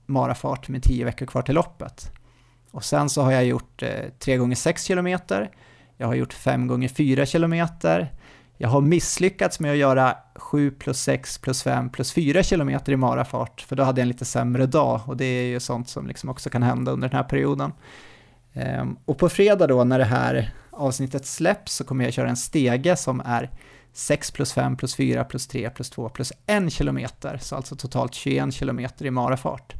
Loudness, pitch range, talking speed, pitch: -23 LUFS, 125-145 Hz, 190 wpm, 130 Hz